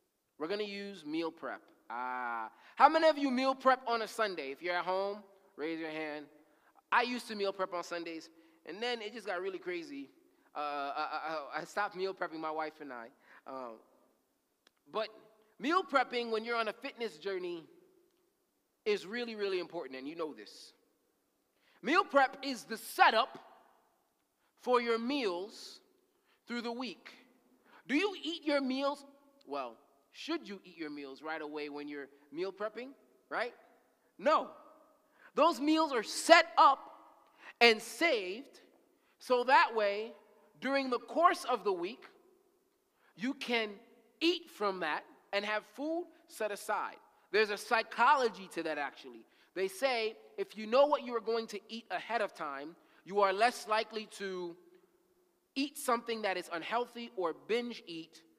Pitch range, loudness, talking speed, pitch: 180-280 Hz, -34 LUFS, 160 wpm, 225 Hz